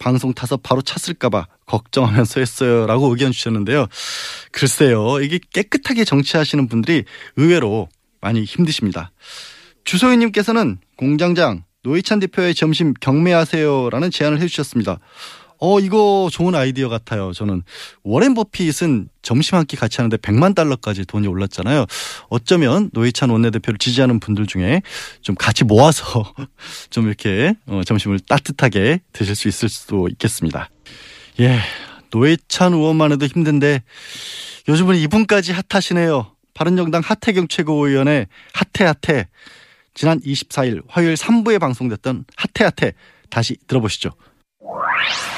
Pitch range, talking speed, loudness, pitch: 115-170 Hz, 315 characters per minute, -17 LUFS, 135 Hz